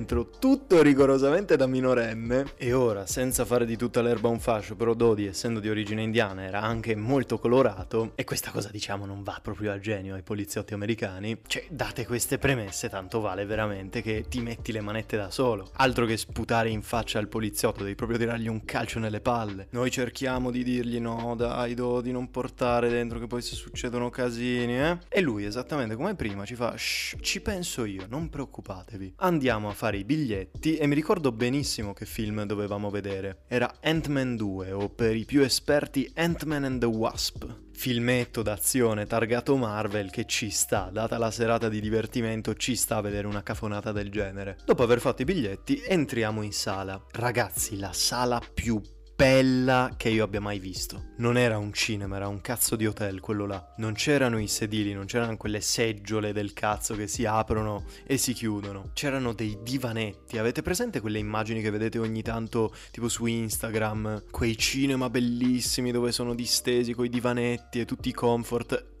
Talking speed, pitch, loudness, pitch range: 180 wpm, 115 Hz, -28 LUFS, 105-125 Hz